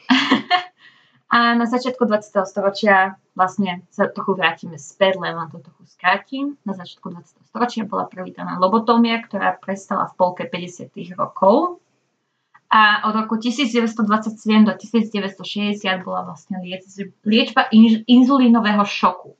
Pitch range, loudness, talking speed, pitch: 185-235 Hz, -18 LUFS, 115 wpm, 205 Hz